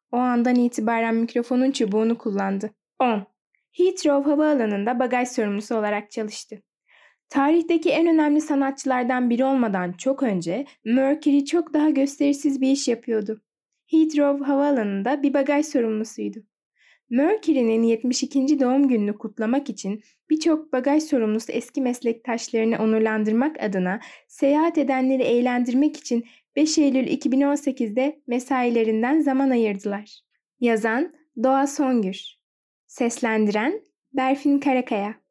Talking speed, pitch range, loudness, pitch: 105 wpm, 225-285 Hz, -22 LUFS, 255 Hz